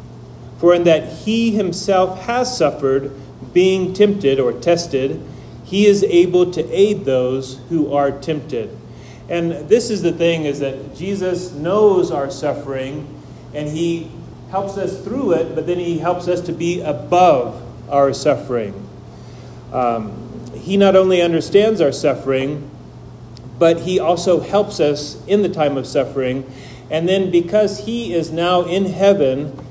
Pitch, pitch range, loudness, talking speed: 165 Hz, 135-185 Hz, -17 LUFS, 145 wpm